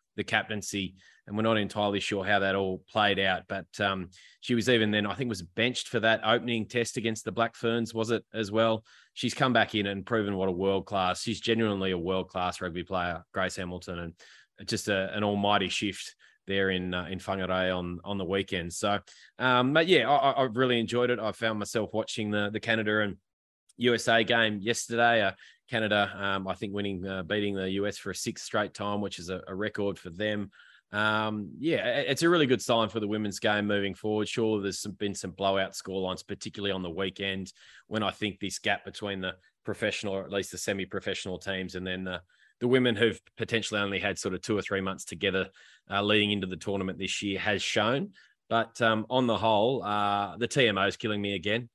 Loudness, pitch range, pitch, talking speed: -29 LUFS, 95-110 Hz, 100 Hz, 215 wpm